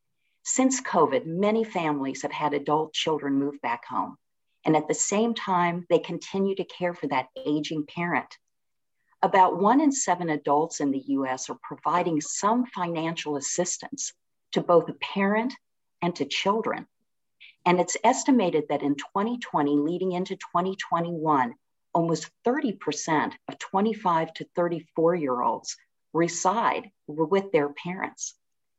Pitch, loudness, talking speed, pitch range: 175 Hz, -26 LUFS, 135 wpm, 150-195 Hz